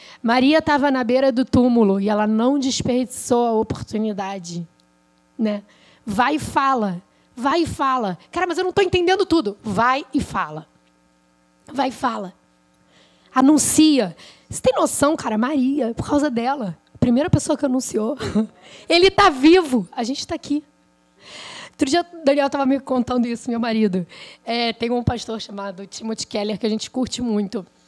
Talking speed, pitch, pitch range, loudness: 160 wpm, 240 Hz, 205-280 Hz, -20 LUFS